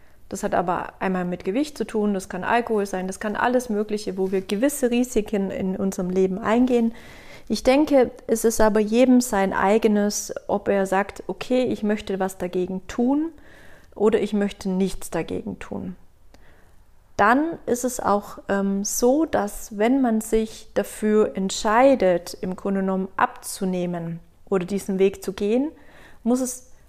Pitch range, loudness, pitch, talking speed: 195-240 Hz, -23 LUFS, 210 Hz, 155 wpm